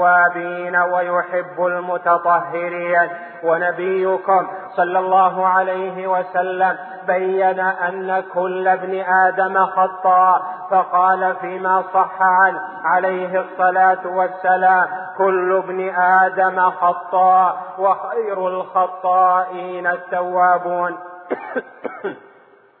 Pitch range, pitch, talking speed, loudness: 180-185 Hz, 185 Hz, 75 wpm, -18 LUFS